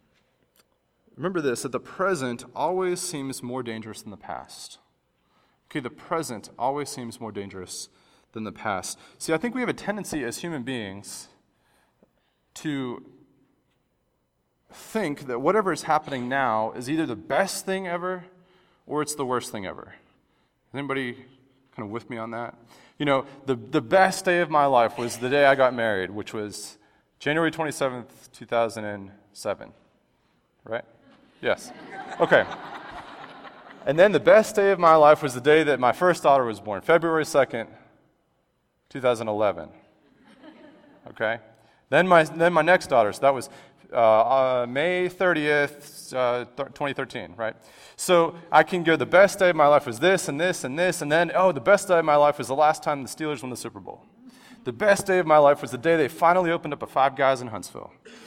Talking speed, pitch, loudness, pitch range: 180 wpm, 145 Hz, -23 LUFS, 125-175 Hz